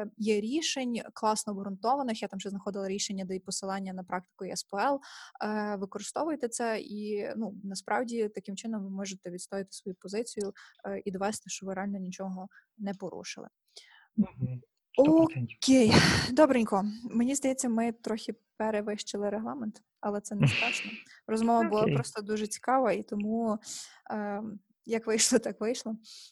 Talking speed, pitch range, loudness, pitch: 130 wpm, 195-230 Hz, -31 LUFS, 210 Hz